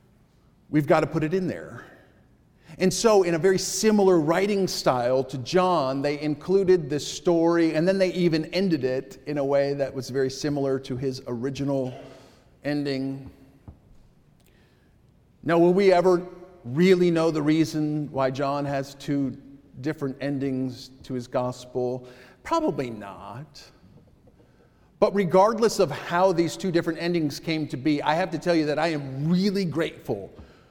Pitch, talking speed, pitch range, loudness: 155 Hz, 150 wpm, 135-180 Hz, -24 LUFS